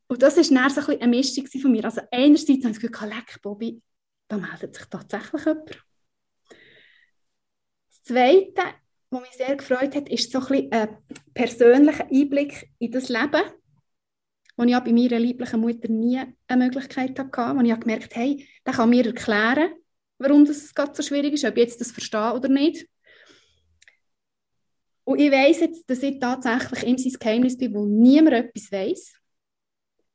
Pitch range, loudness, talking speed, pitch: 235-285 Hz, -21 LUFS, 170 wpm, 255 Hz